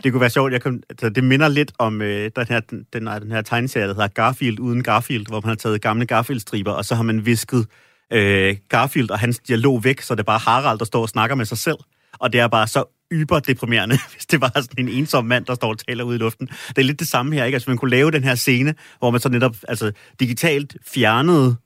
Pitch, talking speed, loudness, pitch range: 120 Hz, 260 wpm, -19 LUFS, 115-135 Hz